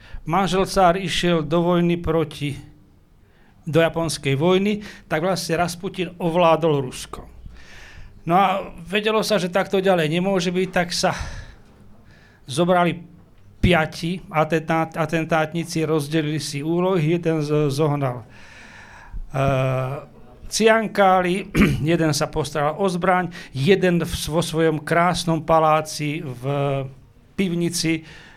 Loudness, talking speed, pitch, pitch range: -21 LUFS, 105 wpm, 165 Hz, 150-180 Hz